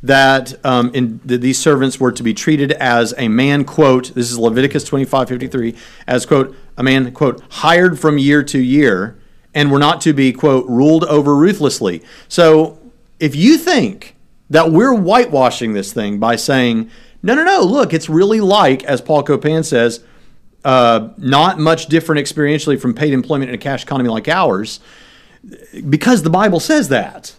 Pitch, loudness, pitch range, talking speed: 140 Hz, -13 LUFS, 125-155 Hz, 175 wpm